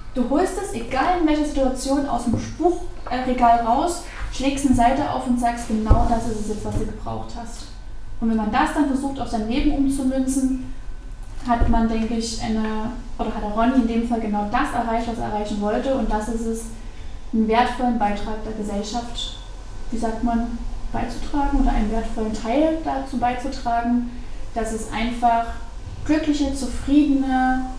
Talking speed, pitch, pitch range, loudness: 170 wpm, 235 Hz, 225-265 Hz, -22 LUFS